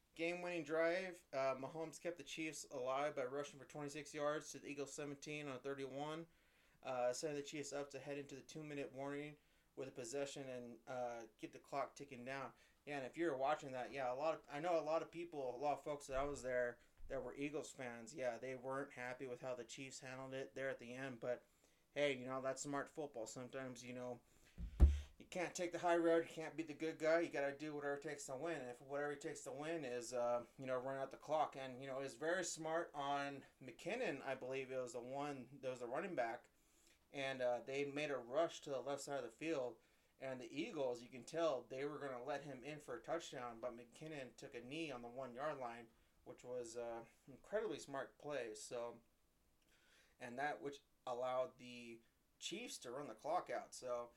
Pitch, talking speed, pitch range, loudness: 135 Hz, 230 wpm, 125-150 Hz, -46 LUFS